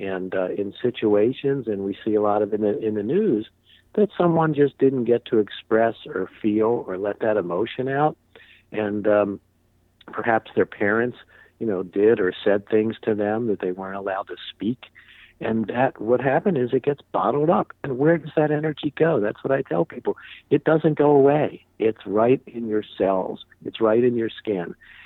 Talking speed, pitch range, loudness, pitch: 195 wpm, 105-140 Hz, -22 LUFS, 110 Hz